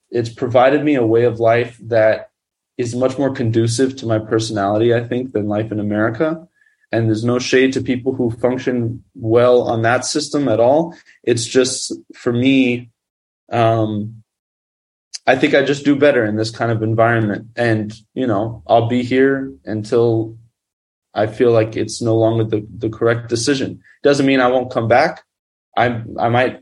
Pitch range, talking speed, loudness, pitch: 110-130 Hz, 175 wpm, -17 LUFS, 120 Hz